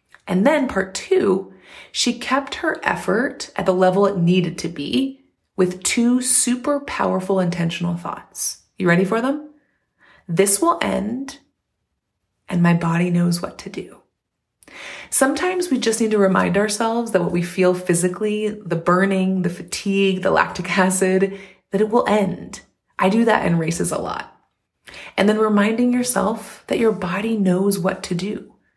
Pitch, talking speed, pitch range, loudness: 195 Hz, 160 wpm, 185-235 Hz, -19 LUFS